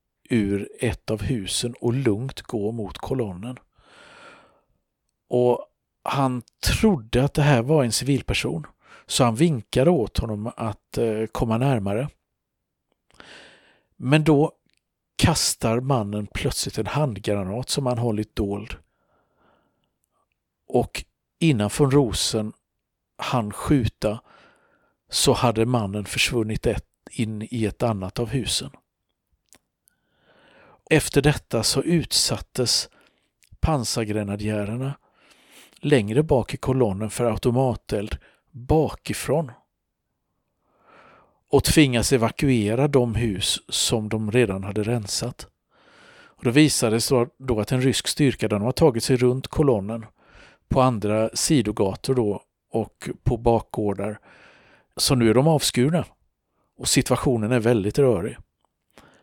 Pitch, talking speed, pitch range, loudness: 120 Hz, 105 wpm, 110-135 Hz, -23 LUFS